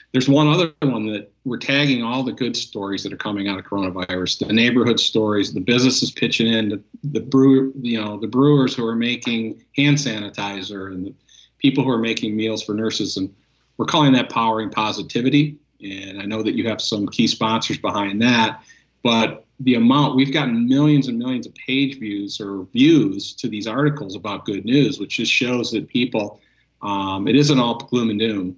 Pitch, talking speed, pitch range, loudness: 115 Hz, 195 wpm, 105-135 Hz, -19 LUFS